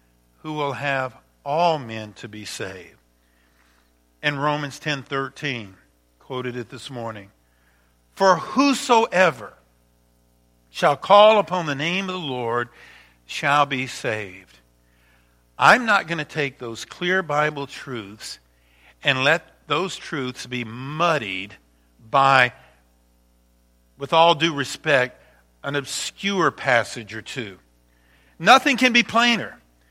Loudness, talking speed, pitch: -21 LUFS, 115 wpm, 120 Hz